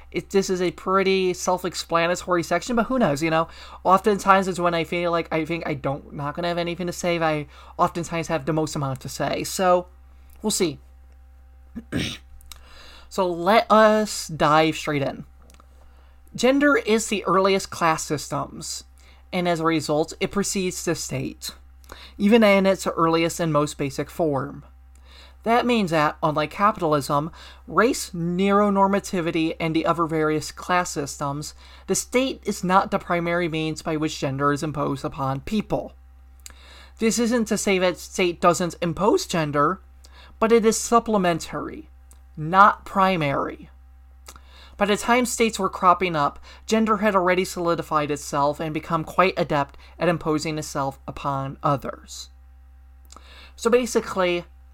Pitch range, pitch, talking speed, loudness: 140-190 Hz, 165 Hz, 145 wpm, -22 LUFS